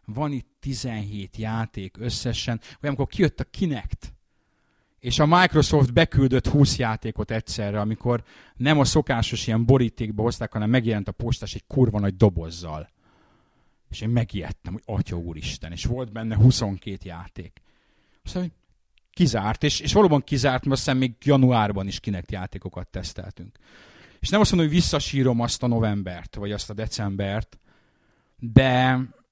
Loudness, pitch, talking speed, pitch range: -23 LUFS, 115 Hz, 145 wpm, 100-130 Hz